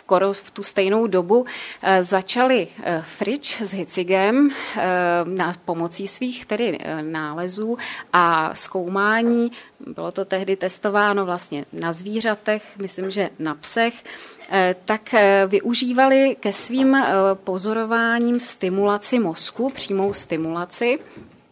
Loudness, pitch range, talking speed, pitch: -21 LUFS, 185-230 Hz, 100 wpm, 200 Hz